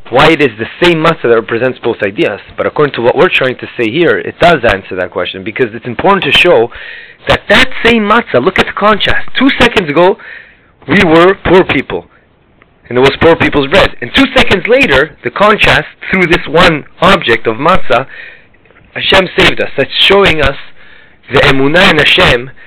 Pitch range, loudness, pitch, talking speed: 140-205 Hz, -8 LUFS, 170 Hz, 190 wpm